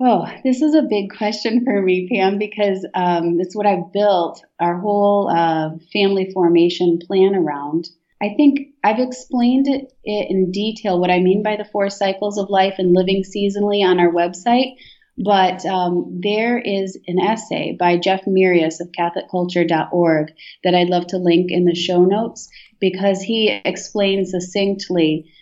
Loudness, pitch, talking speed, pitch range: -18 LUFS, 190 Hz, 160 wpm, 175-210 Hz